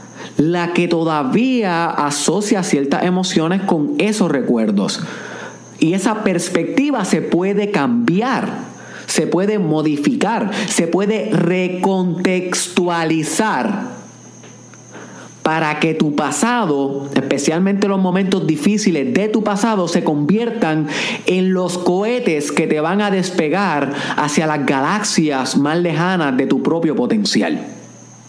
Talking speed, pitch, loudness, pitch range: 110 wpm, 180 Hz, -17 LUFS, 160-205 Hz